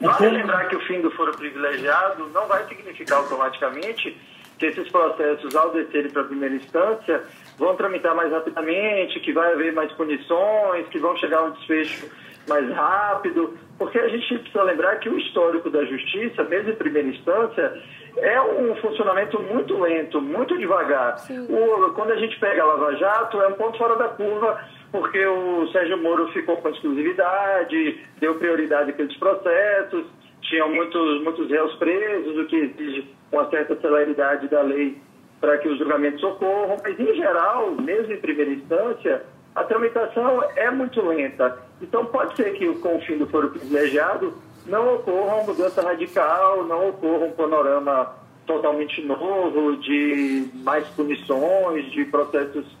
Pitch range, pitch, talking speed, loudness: 150-220 Hz, 170 Hz, 155 wpm, -22 LUFS